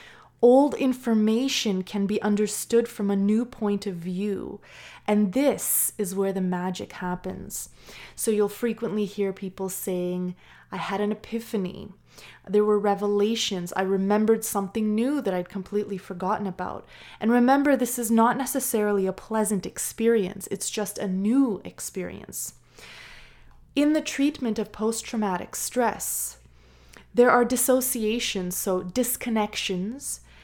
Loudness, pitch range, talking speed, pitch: -25 LUFS, 195-230 Hz, 130 wpm, 210 Hz